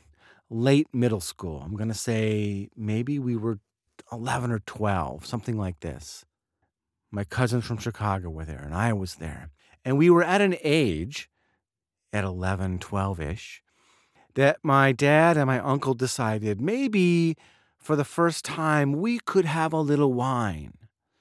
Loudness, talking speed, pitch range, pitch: -25 LUFS, 155 wpm, 95-145 Hz, 115 Hz